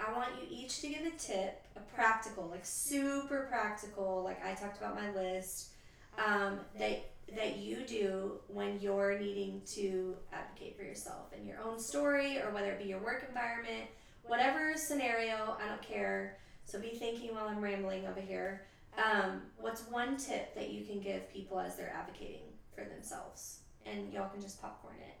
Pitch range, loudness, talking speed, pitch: 190-235 Hz, -39 LUFS, 180 wpm, 205 Hz